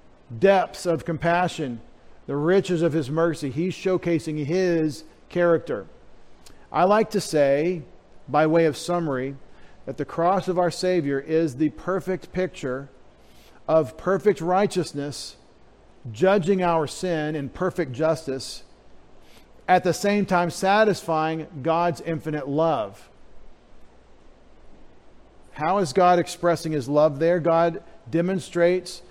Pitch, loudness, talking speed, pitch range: 165 Hz, -23 LUFS, 115 wpm, 150-180 Hz